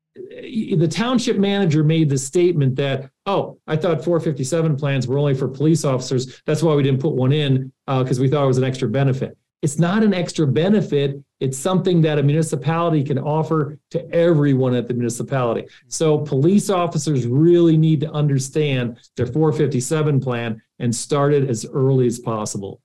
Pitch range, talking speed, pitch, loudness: 130-165 Hz, 175 wpm, 145 Hz, -19 LUFS